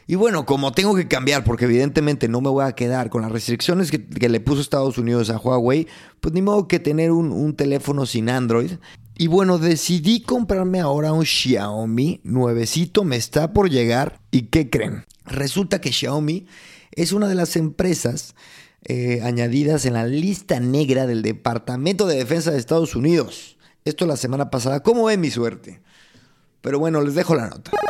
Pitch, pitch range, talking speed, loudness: 145 Hz, 125-170 Hz, 180 wpm, -20 LUFS